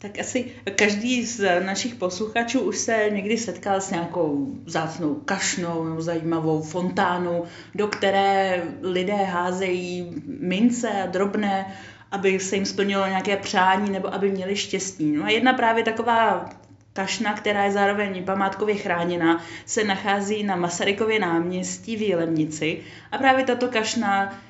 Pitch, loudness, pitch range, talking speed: 195 Hz, -23 LUFS, 175-210 Hz, 135 wpm